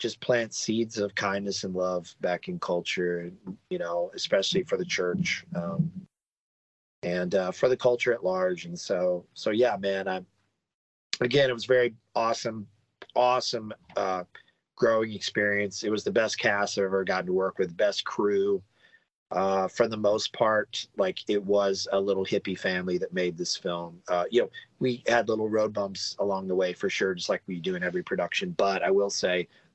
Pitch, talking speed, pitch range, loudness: 100 Hz, 185 wpm, 95-120 Hz, -28 LUFS